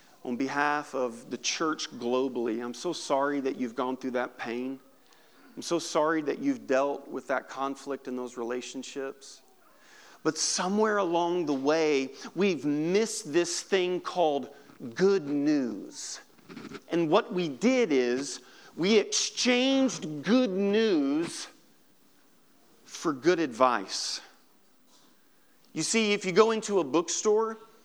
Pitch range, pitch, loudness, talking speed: 135-220 Hz, 170 Hz, -28 LUFS, 125 wpm